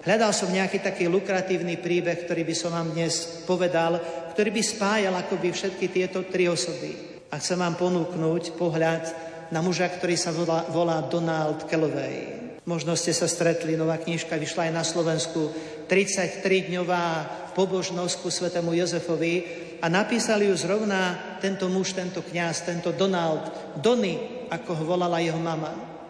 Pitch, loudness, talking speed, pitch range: 170 Hz, -26 LUFS, 145 wpm, 165-185 Hz